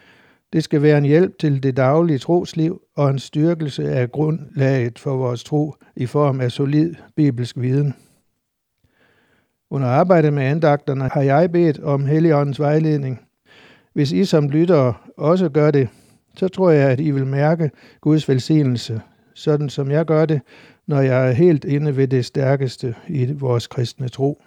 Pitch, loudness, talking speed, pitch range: 145 Hz, -18 LUFS, 160 wpm, 135-155 Hz